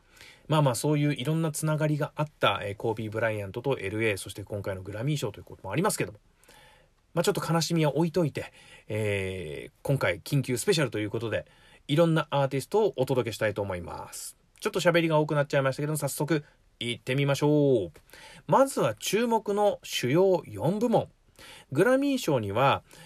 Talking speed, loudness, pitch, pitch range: 420 characters per minute, -27 LUFS, 145 Hz, 115-170 Hz